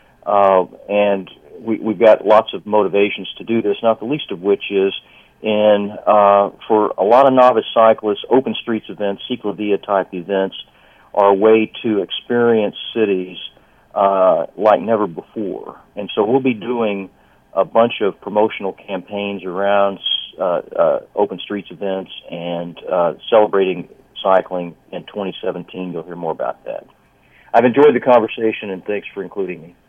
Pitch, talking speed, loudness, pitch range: 100 Hz, 155 wpm, -17 LUFS, 95-110 Hz